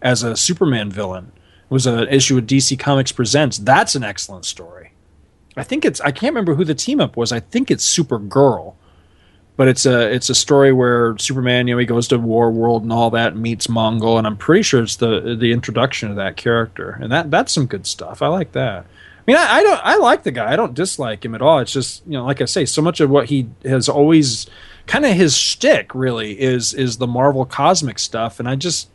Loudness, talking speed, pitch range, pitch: -16 LUFS, 235 wpm, 115-140 Hz, 125 Hz